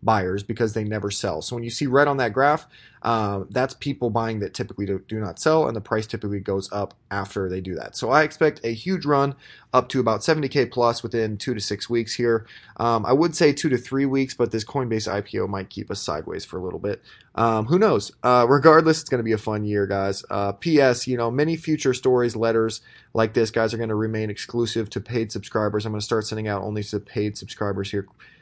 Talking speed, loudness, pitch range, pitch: 240 wpm, -23 LUFS, 105-130 Hz, 115 Hz